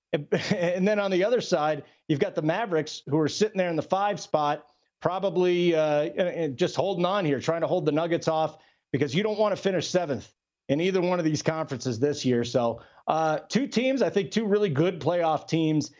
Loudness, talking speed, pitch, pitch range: -26 LUFS, 210 wpm, 165 Hz, 150-190 Hz